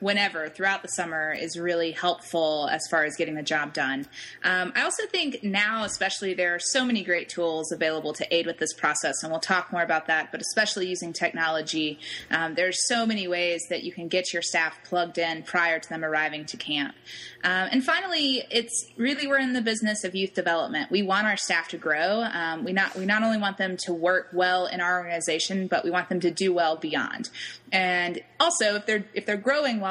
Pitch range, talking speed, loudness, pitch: 165-200 Hz, 220 wpm, -26 LUFS, 180 Hz